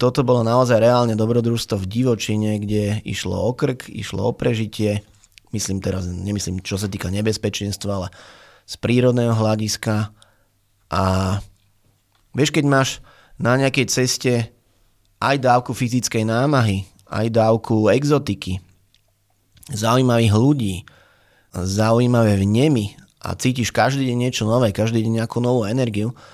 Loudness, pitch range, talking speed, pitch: -20 LUFS, 100-120 Hz, 125 wpm, 110 Hz